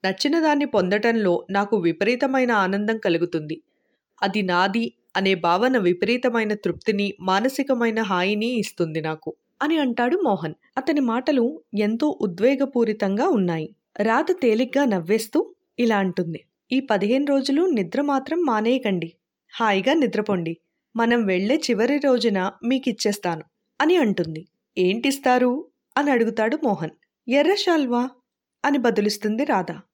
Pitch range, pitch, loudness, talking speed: 195-265 Hz, 225 Hz, -22 LUFS, 105 wpm